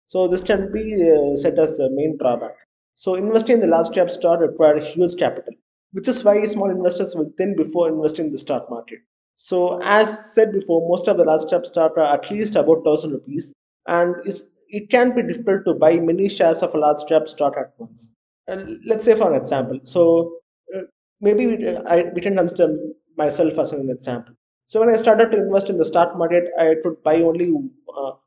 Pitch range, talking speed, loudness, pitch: 155-200 Hz, 200 wpm, -19 LUFS, 170 Hz